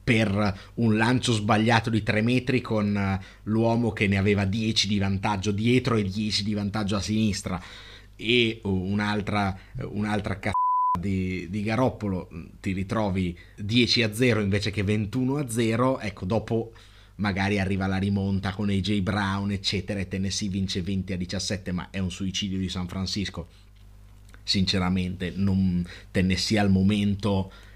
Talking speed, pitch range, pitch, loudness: 145 wpm, 95-110 Hz, 100 Hz, -26 LUFS